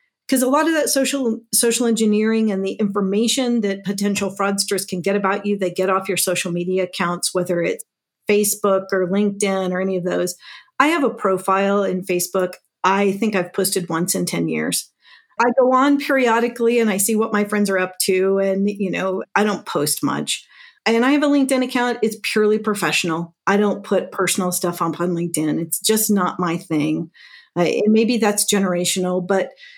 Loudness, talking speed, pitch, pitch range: -19 LUFS, 195 wpm, 200 Hz, 185-225 Hz